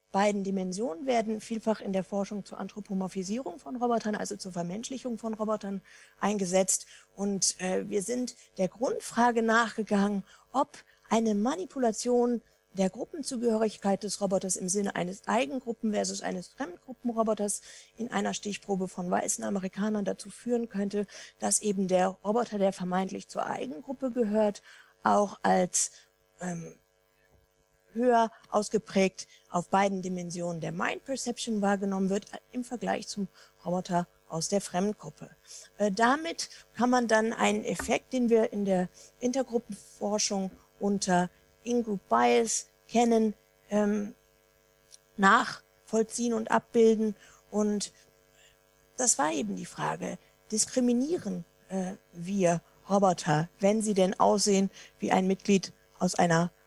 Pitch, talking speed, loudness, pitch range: 205 Hz, 120 wpm, -29 LUFS, 185-230 Hz